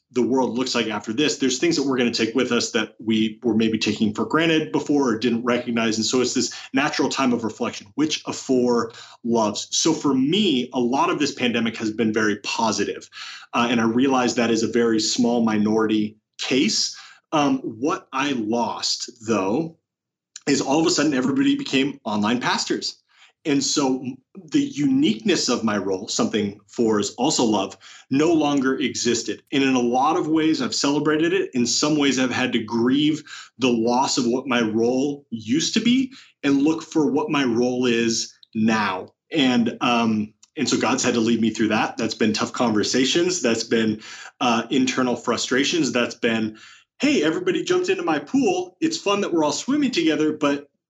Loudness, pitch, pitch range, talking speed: -21 LUFS, 130 Hz, 115-155 Hz, 185 wpm